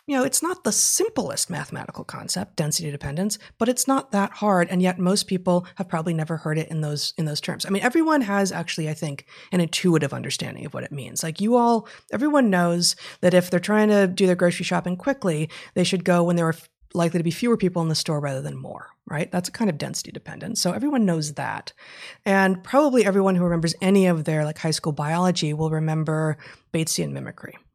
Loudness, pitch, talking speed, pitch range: -23 LUFS, 175 Hz, 220 wpm, 160-200 Hz